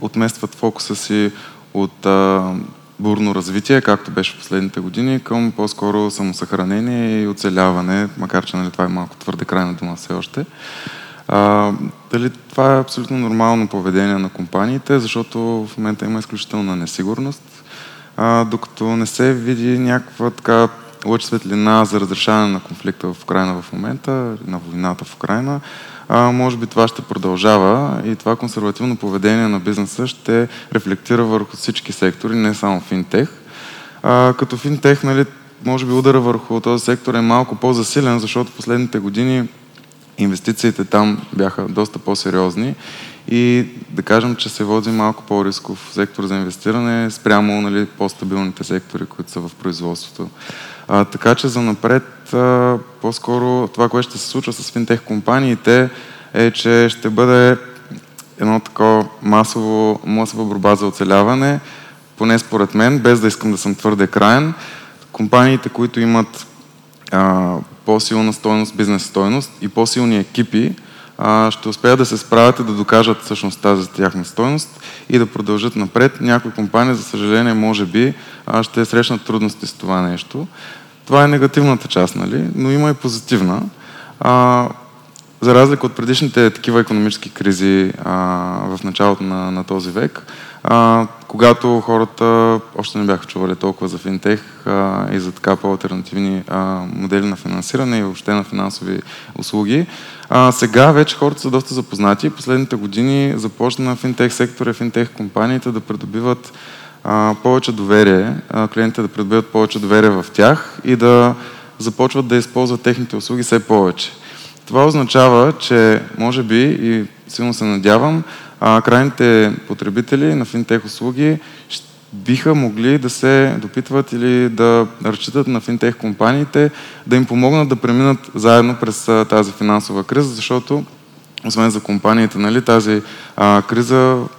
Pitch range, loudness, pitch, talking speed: 105-125 Hz, -15 LUFS, 115 Hz, 145 wpm